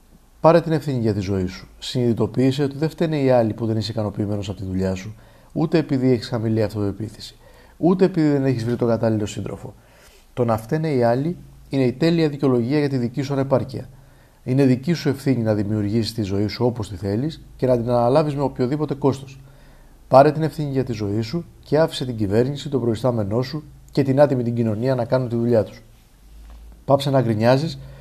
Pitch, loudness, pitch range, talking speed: 130 Hz, -21 LUFS, 110-140 Hz, 200 wpm